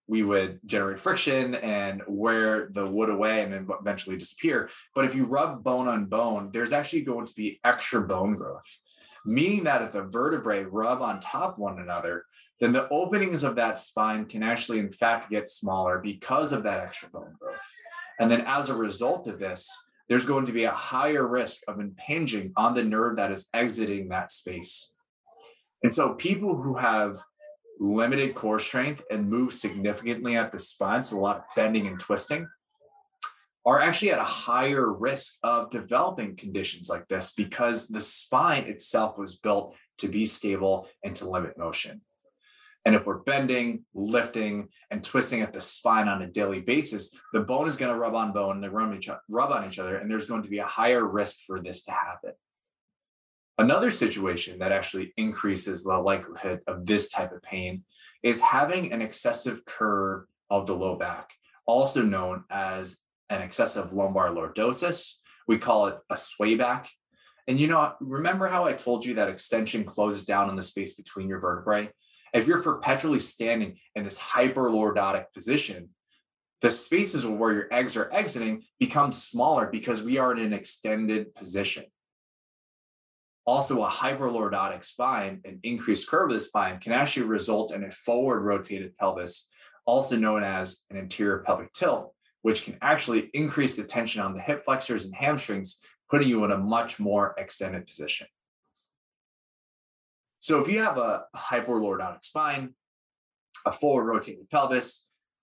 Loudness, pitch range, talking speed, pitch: -27 LUFS, 100-135 Hz, 170 wpm, 110 Hz